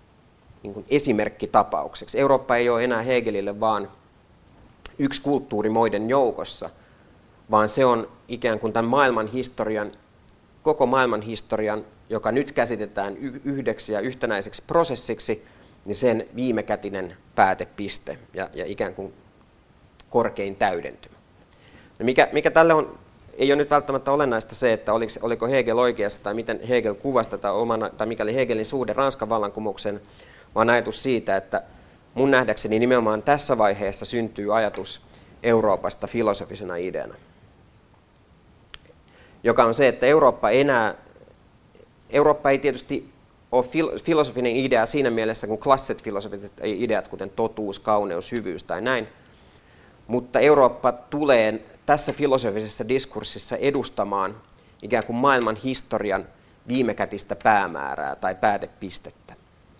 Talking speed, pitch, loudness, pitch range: 120 wpm, 115 Hz, -23 LUFS, 105-130 Hz